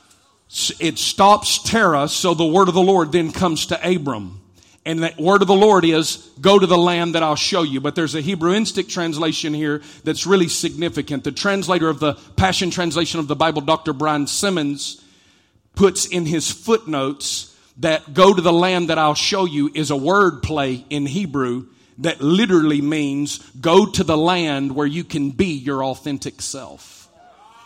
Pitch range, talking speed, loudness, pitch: 145-180 Hz, 180 wpm, -18 LUFS, 160 Hz